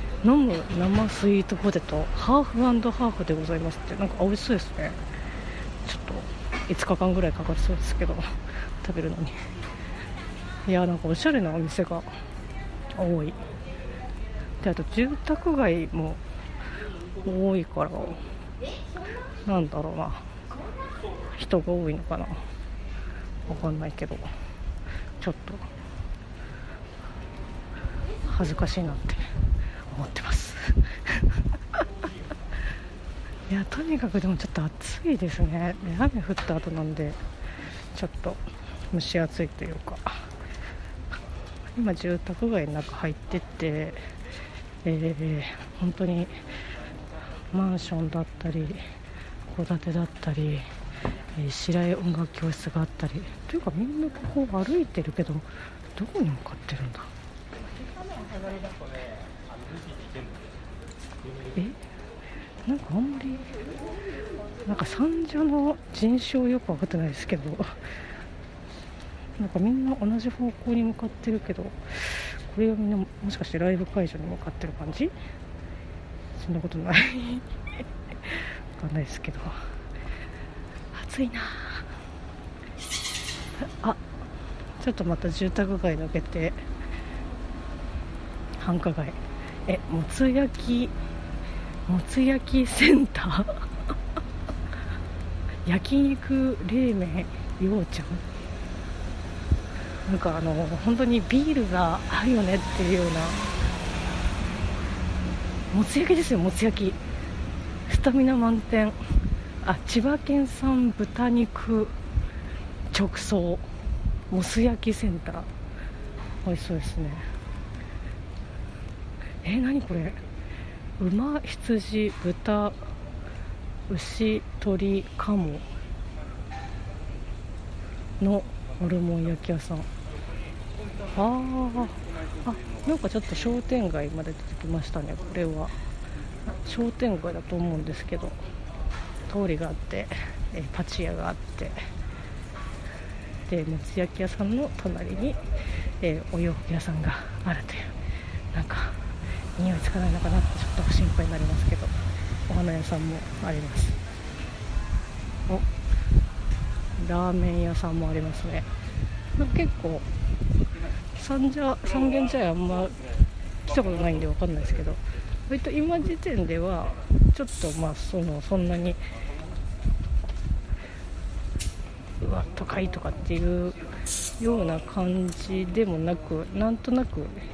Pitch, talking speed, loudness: 155 Hz, 220 characters per minute, -29 LUFS